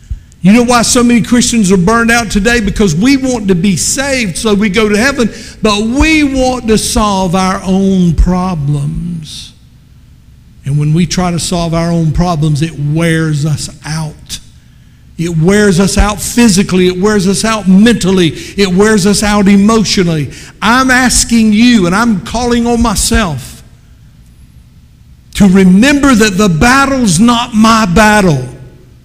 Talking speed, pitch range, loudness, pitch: 150 wpm, 170-230 Hz, -9 LUFS, 200 Hz